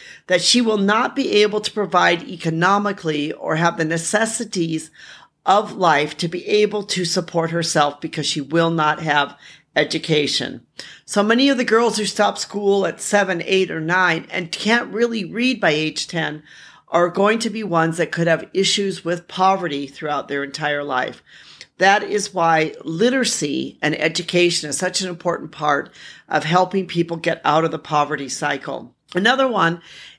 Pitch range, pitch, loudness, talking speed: 155-205 Hz, 175 Hz, -19 LUFS, 165 wpm